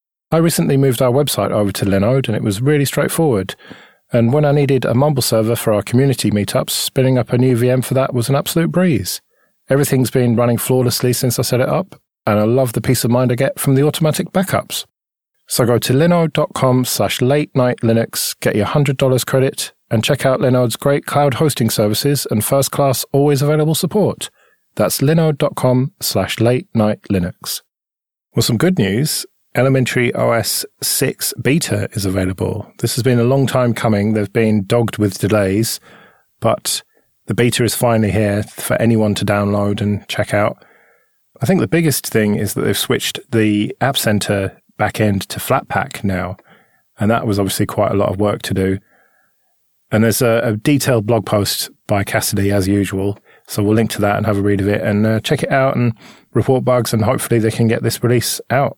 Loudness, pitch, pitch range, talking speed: -16 LUFS, 120 Hz, 105-135 Hz, 195 wpm